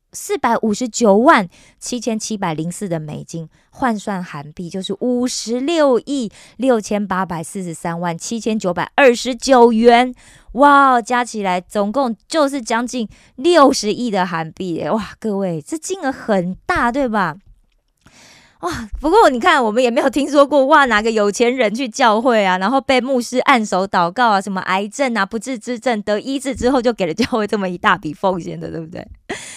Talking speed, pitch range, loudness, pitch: 265 characters per minute, 190-255 Hz, -16 LUFS, 225 Hz